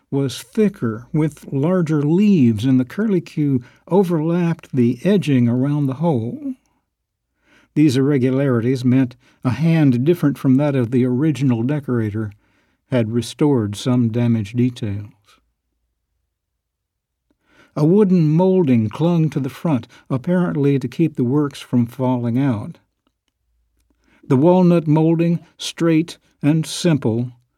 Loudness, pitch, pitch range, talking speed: -18 LUFS, 135 Hz, 120-160 Hz, 115 wpm